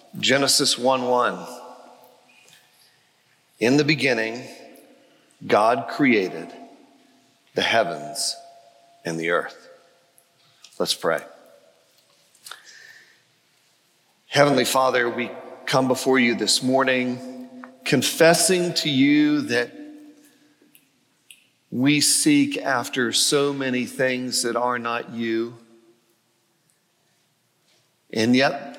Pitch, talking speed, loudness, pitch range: 130 Hz, 80 wpm, -21 LUFS, 115-165 Hz